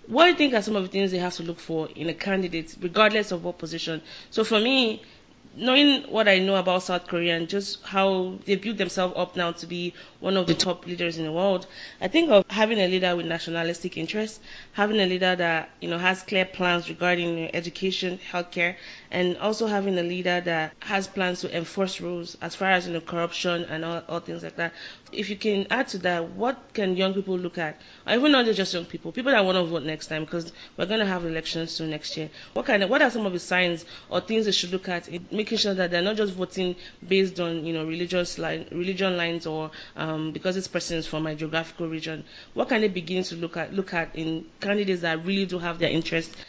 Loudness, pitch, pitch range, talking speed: -25 LUFS, 180 Hz, 170-195 Hz, 235 wpm